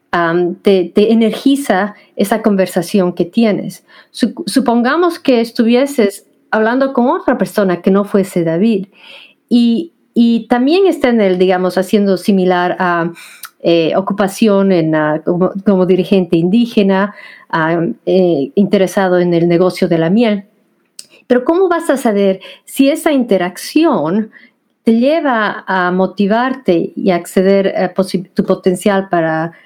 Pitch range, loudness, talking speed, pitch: 185-235 Hz, -13 LUFS, 130 wpm, 200 Hz